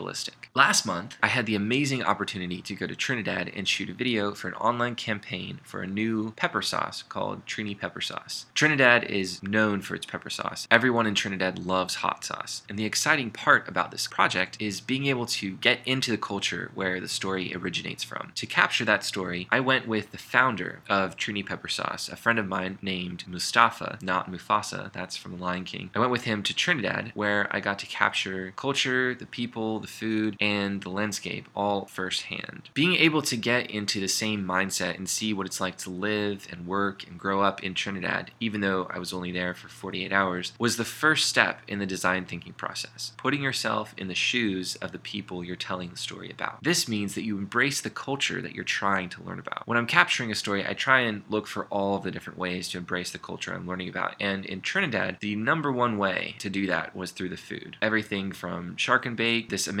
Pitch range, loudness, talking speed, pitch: 95-115 Hz, -27 LUFS, 215 wpm, 100 Hz